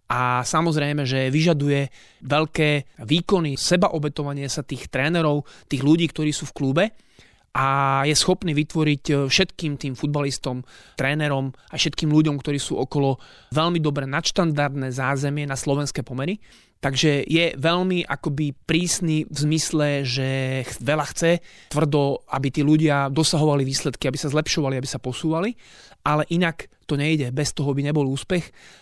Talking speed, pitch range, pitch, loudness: 140 wpm, 135-155 Hz, 145 Hz, -22 LUFS